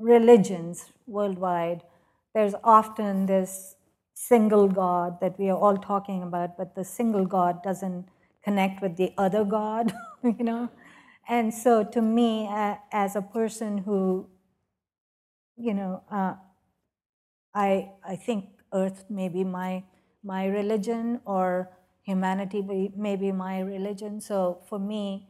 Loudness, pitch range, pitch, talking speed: -26 LUFS, 190-215 Hz, 195 Hz, 130 wpm